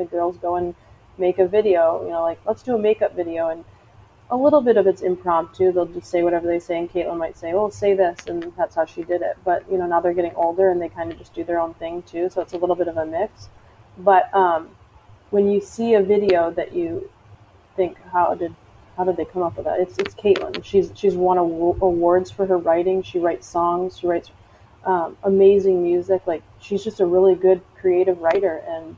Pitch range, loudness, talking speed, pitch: 170-190 Hz, -20 LUFS, 235 wpm, 175 Hz